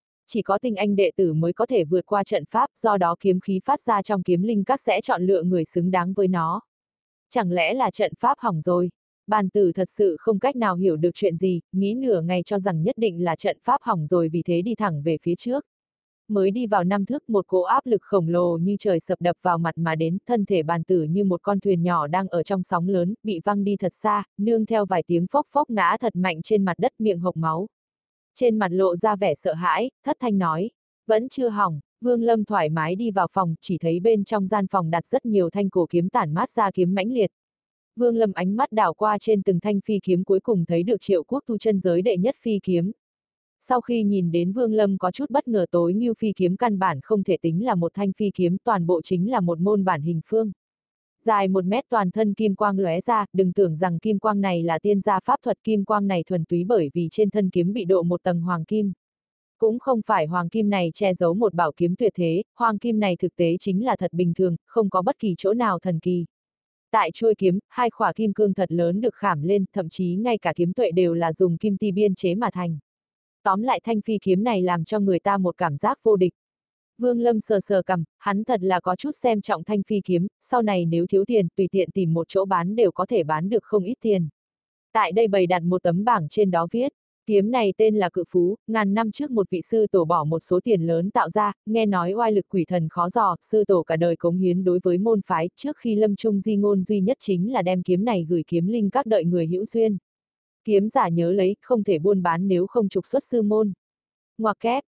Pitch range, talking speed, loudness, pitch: 180-220 Hz, 255 wpm, -23 LUFS, 195 Hz